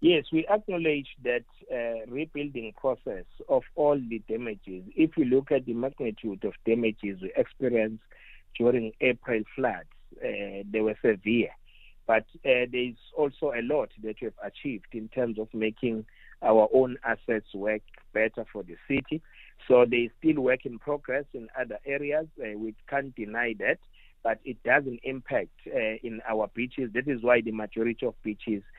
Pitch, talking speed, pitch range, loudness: 120 Hz, 165 wpm, 110-130 Hz, -29 LUFS